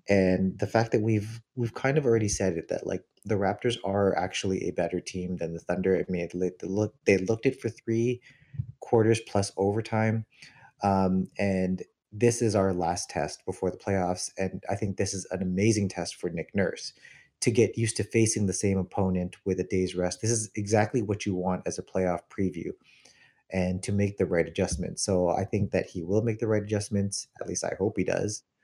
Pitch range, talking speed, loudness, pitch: 95-110 Hz, 205 wpm, -28 LUFS, 100 Hz